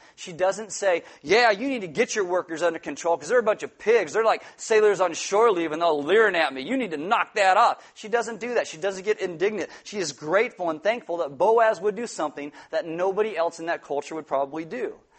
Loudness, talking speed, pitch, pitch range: -24 LUFS, 245 wpm, 195 Hz, 165-230 Hz